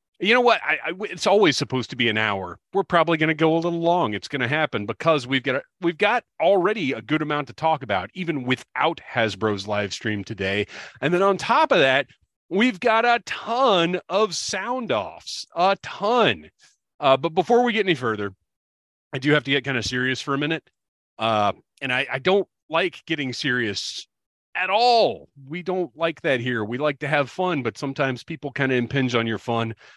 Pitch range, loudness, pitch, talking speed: 115-175 Hz, -22 LUFS, 145 Hz, 210 wpm